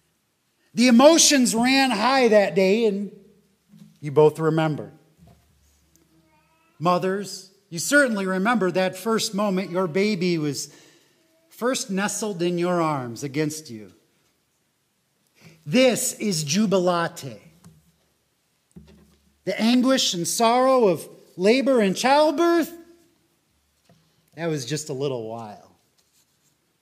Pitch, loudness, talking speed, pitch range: 190 Hz, -21 LUFS, 100 wpm, 160-225 Hz